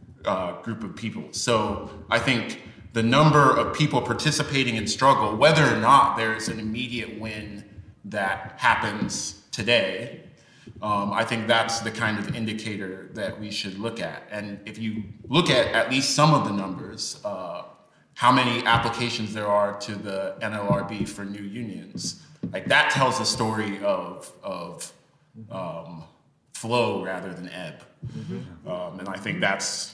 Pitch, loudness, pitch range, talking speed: 110 Hz, -24 LUFS, 100-120 Hz, 155 wpm